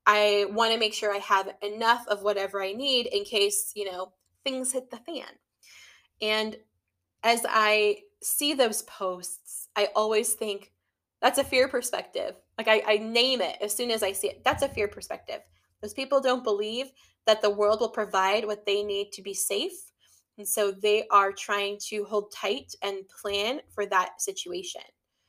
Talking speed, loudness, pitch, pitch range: 180 wpm, -27 LUFS, 210 Hz, 200-245 Hz